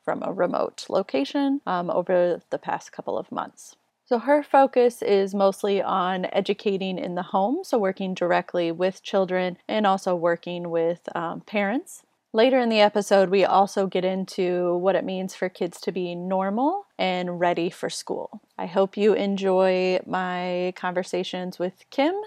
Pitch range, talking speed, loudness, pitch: 180-205 Hz, 160 wpm, -24 LUFS, 190 Hz